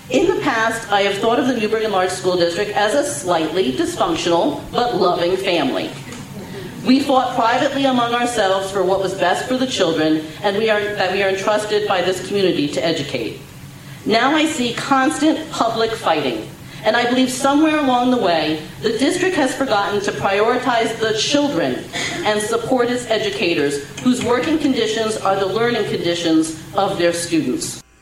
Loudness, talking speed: -18 LUFS, 170 wpm